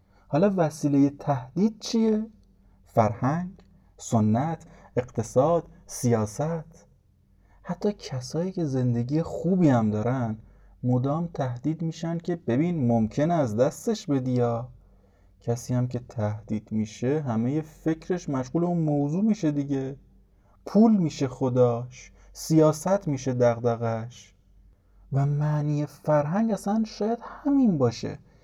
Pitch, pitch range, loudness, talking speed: 140 Hz, 115-165 Hz, -26 LUFS, 105 wpm